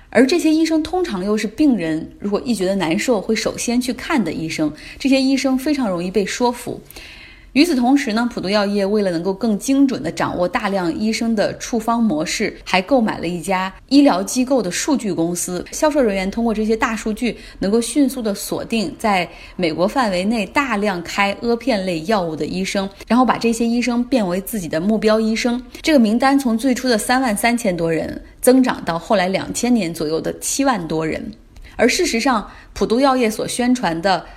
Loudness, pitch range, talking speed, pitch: -18 LUFS, 190-255 Hz, 300 characters per minute, 225 Hz